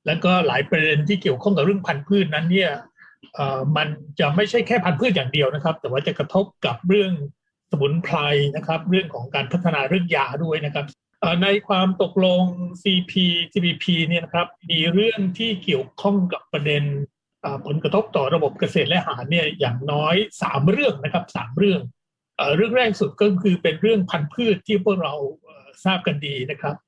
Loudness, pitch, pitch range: -21 LUFS, 175 Hz, 150-195 Hz